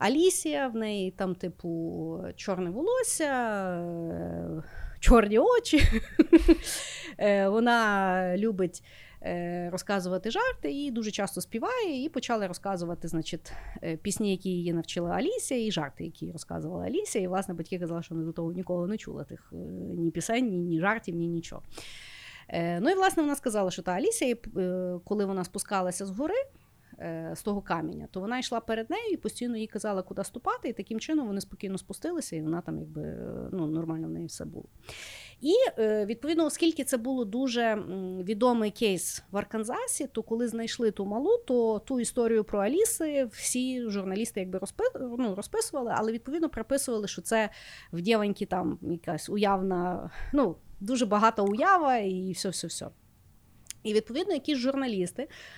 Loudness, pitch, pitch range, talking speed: -29 LUFS, 210 Hz, 180-260 Hz, 150 wpm